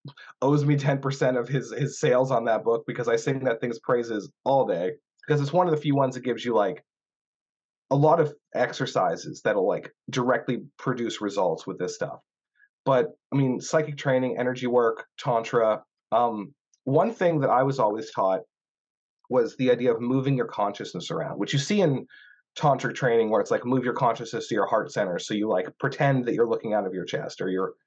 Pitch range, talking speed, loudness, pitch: 120-155 Hz, 205 wpm, -25 LUFS, 135 Hz